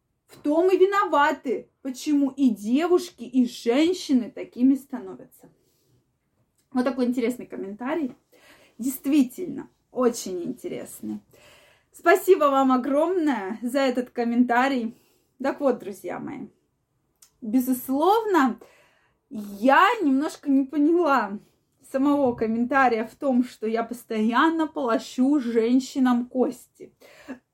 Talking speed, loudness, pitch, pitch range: 95 wpm, -23 LUFS, 265 Hz, 240-290 Hz